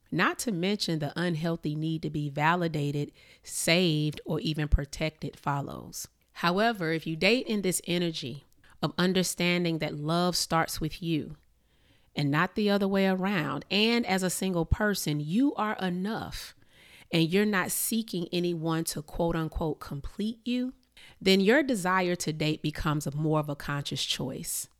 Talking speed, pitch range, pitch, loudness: 155 wpm, 155-195 Hz, 170 Hz, -29 LUFS